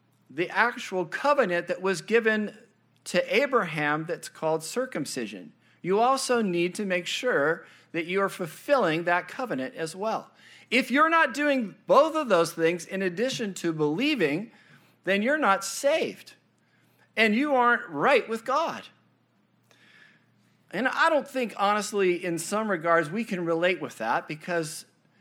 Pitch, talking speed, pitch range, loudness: 200 Hz, 145 wpm, 175-255 Hz, -26 LUFS